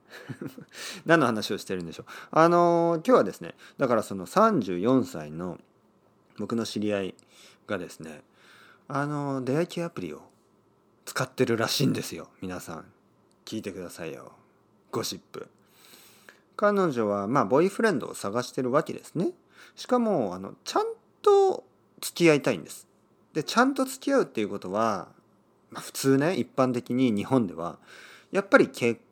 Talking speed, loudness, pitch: 305 characters per minute, -26 LUFS, 135 Hz